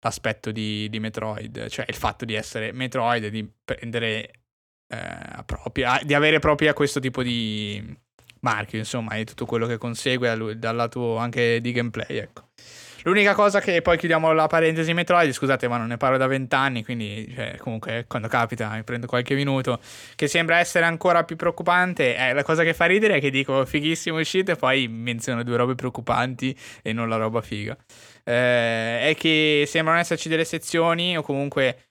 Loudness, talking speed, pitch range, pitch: -22 LUFS, 180 wpm, 115-155 Hz, 125 Hz